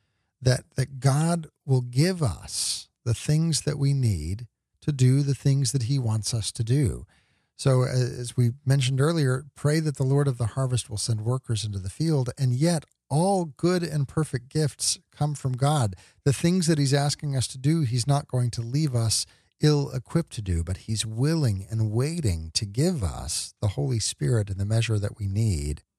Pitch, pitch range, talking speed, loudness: 130 Hz, 110-145 Hz, 190 wpm, -26 LUFS